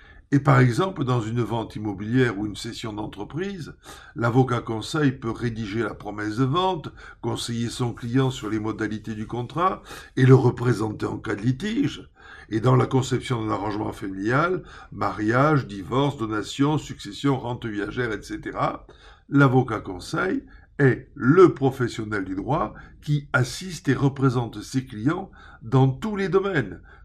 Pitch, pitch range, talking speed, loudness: 120 Hz, 110-135 Hz, 145 wpm, -24 LUFS